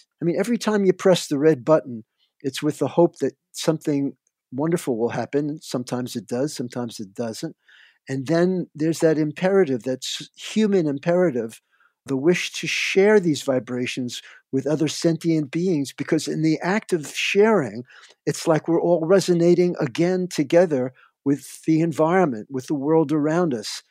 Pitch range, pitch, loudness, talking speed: 135-175 Hz, 155 Hz, -22 LUFS, 160 wpm